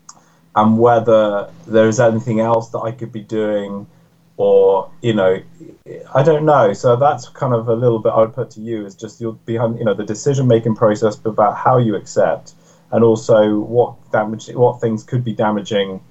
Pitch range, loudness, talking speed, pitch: 110-120 Hz, -16 LUFS, 200 wpm, 115 Hz